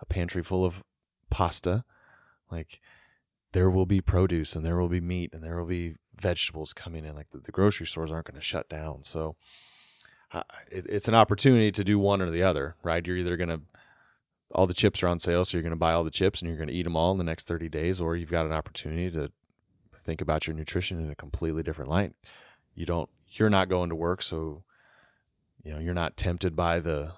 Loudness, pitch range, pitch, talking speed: -28 LUFS, 80-95 Hz, 85 Hz, 230 wpm